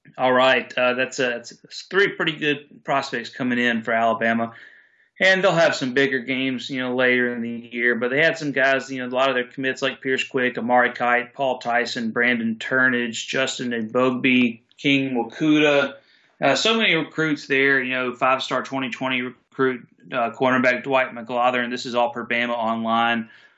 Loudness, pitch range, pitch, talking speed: -21 LUFS, 120-135 Hz, 125 Hz, 180 wpm